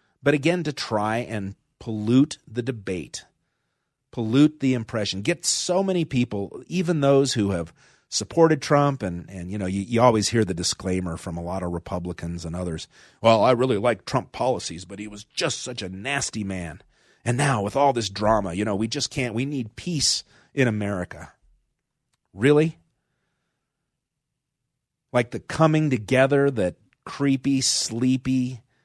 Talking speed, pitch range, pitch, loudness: 160 wpm, 100-140 Hz, 120 Hz, -23 LUFS